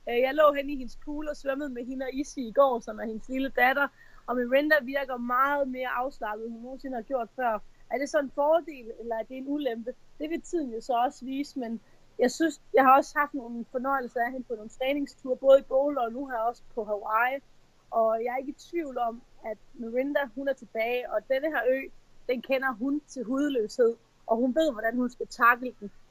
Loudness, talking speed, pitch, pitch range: -28 LUFS, 230 wpm, 260 Hz, 235-280 Hz